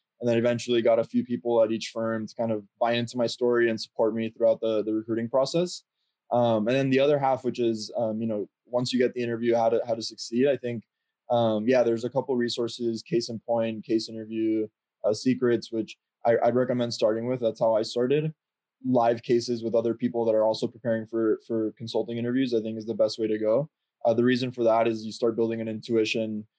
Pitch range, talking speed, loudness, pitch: 110-120 Hz, 230 wpm, -26 LUFS, 115 Hz